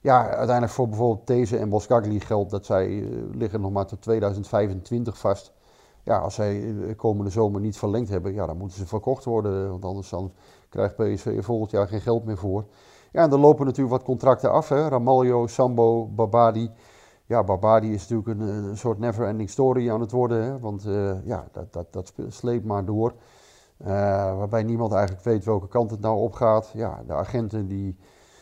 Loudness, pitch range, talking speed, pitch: -24 LUFS, 100-120 Hz, 190 wpm, 110 Hz